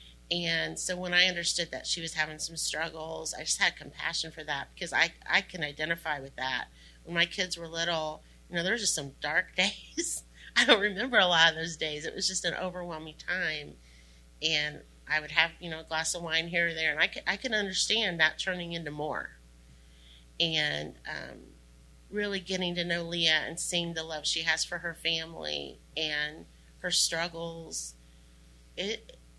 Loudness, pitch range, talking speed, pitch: -30 LUFS, 145-175 Hz, 195 wpm, 160 Hz